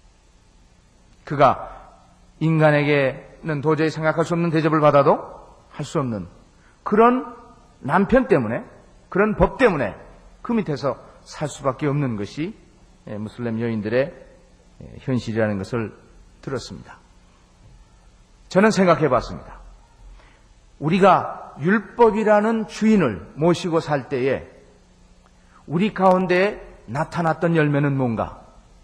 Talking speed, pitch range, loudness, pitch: 230 characters per minute, 125-185 Hz, -20 LUFS, 155 Hz